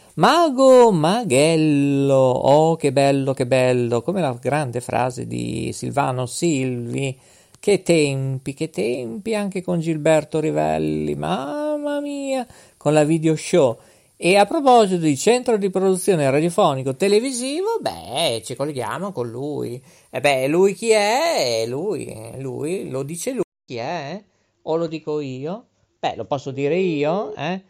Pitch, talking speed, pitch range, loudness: 155 Hz, 140 wpm, 135-200 Hz, -20 LUFS